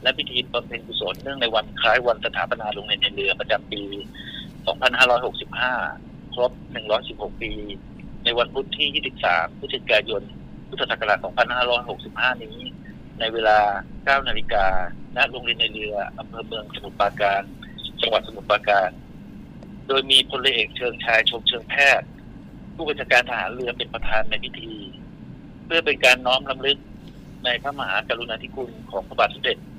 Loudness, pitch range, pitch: -22 LUFS, 100-130 Hz, 115 Hz